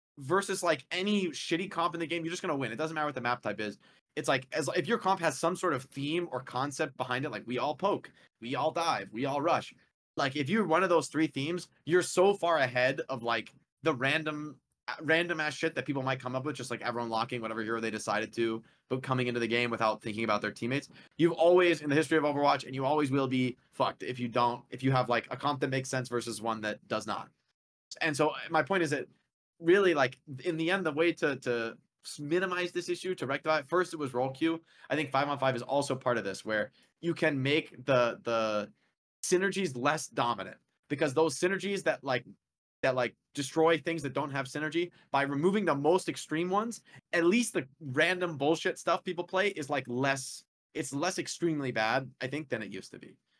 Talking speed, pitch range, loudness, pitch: 230 wpm, 125-170 Hz, -31 LUFS, 150 Hz